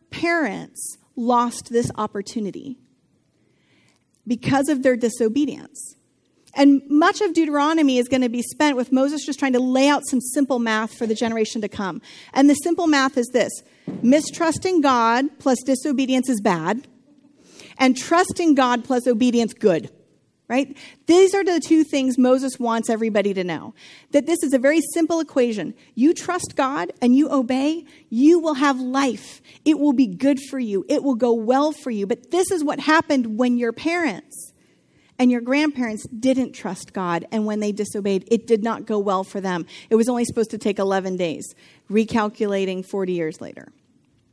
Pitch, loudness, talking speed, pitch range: 255 Hz, -20 LUFS, 170 wpm, 225-290 Hz